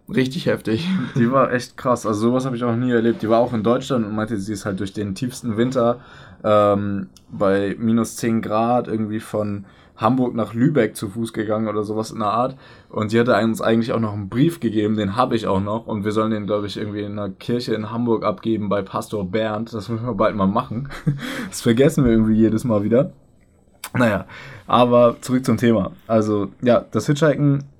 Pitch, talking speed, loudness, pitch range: 110 Hz, 210 wpm, -20 LUFS, 105-120 Hz